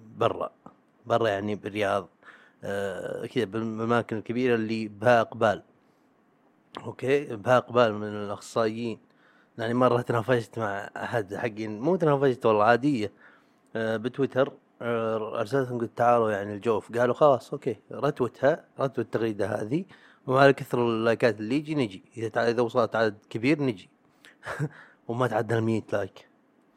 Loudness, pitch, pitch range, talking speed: -27 LUFS, 115 Hz, 110-125 Hz, 125 wpm